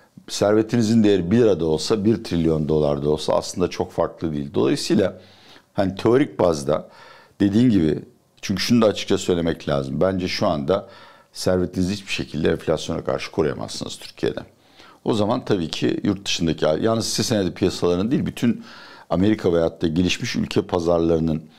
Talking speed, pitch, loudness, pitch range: 155 wpm, 90 Hz, -21 LUFS, 80-100 Hz